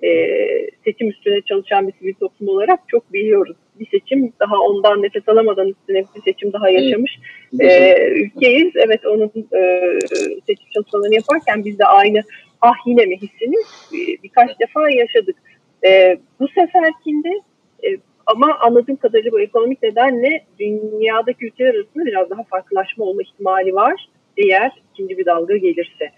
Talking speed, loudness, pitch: 145 wpm, -15 LUFS, 230 Hz